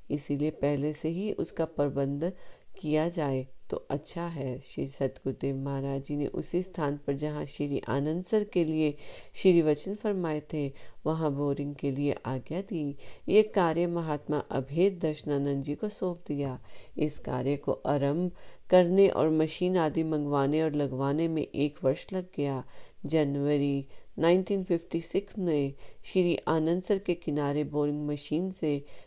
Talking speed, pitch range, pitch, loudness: 130 wpm, 140-170 Hz, 150 Hz, -30 LUFS